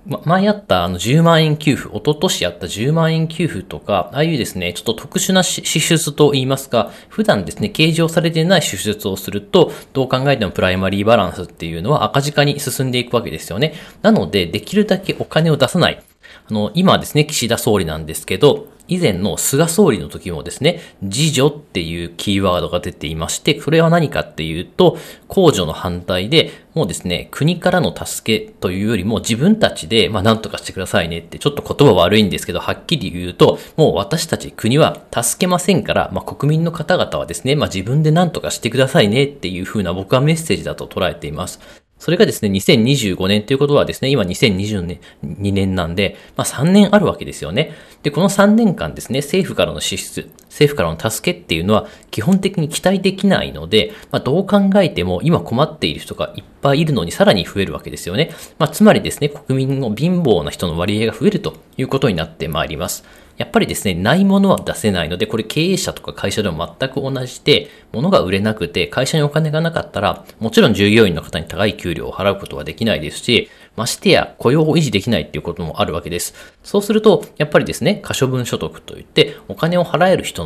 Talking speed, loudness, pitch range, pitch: 425 characters per minute, -16 LUFS, 100-165 Hz, 135 Hz